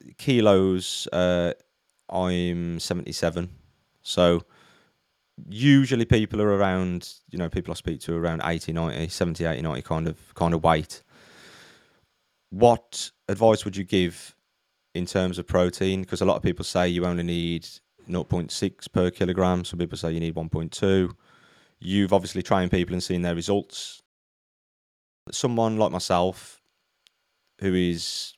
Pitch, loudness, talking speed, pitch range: 90 Hz, -25 LUFS, 140 wpm, 85-100 Hz